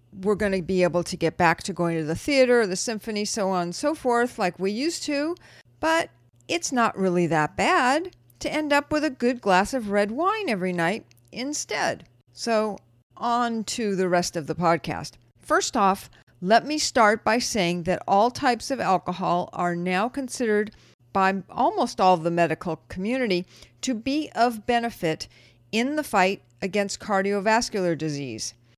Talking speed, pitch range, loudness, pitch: 175 wpm, 175-240 Hz, -24 LUFS, 195 Hz